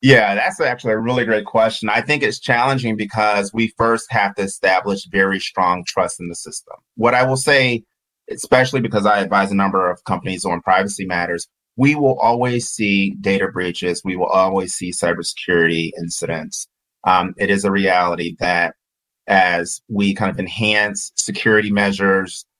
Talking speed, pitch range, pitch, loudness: 165 wpm, 95-115 Hz, 100 Hz, -17 LUFS